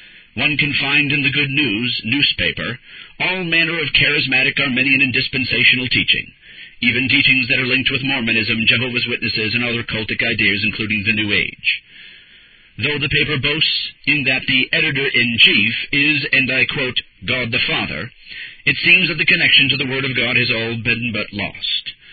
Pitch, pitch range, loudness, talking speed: 130 Hz, 115-145 Hz, -15 LUFS, 175 wpm